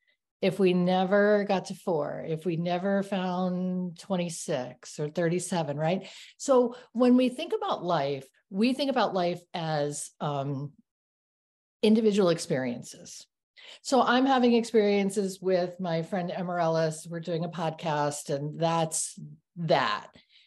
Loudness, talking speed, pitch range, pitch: -28 LUFS, 125 wpm, 160-205 Hz, 180 Hz